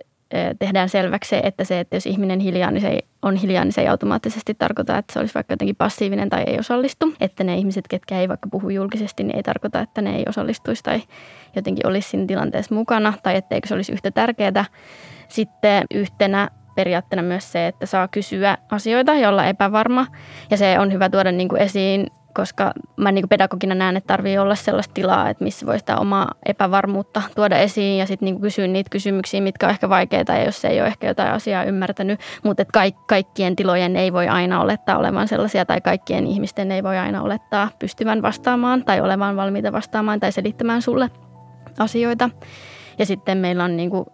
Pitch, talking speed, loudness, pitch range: 195 Hz, 195 wpm, -20 LUFS, 190-210 Hz